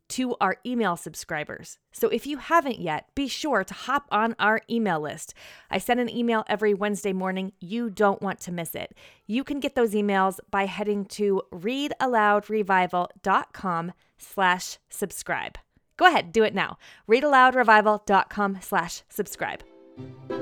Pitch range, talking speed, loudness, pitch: 185-235 Hz, 145 wpm, -25 LUFS, 205 Hz